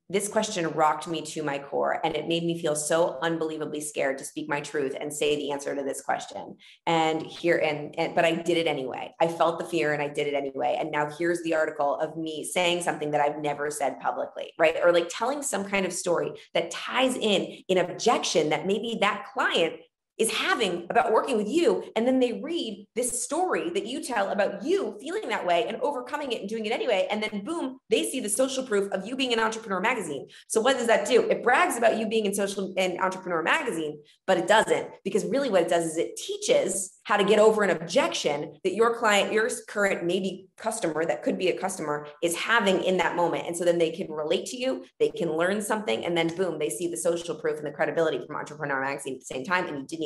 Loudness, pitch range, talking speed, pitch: -26 LUFS, 160-220 Hz, 235 wpm, 180 Hz